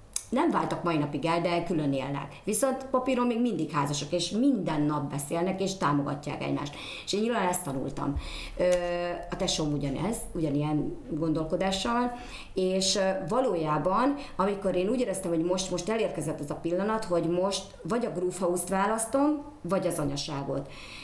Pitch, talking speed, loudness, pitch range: 175 Hz, 150 wpm, -29 LUFS, 150-195 Hz